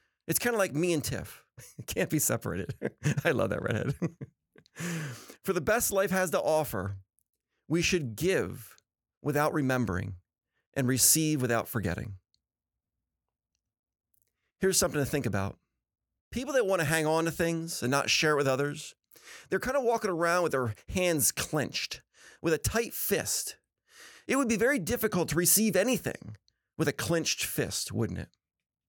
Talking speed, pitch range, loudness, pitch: 160 wpm, 115-175 Hz, -29 LUFS, 150 Hz